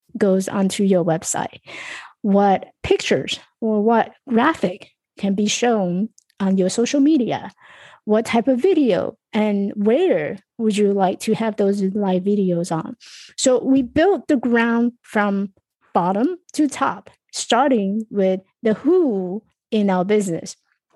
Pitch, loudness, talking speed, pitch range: 215 Hz, -19 LUFS, 135 wpm, 195-245 Hz